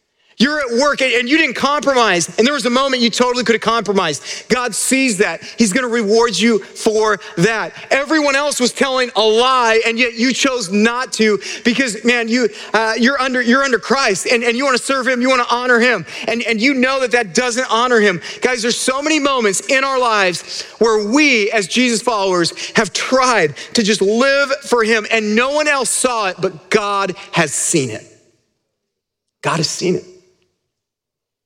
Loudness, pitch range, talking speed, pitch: -15 LUFS, 220-260 Hz, 200 wpm, 235 Hz